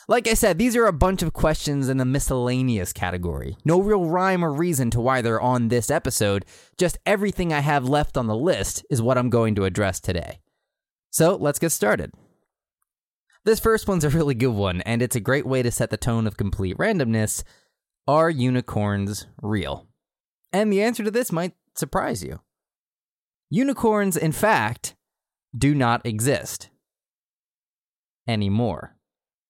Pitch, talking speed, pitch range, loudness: 130 Hz, 165 wpm, 115-180 Hz, -22 LUFS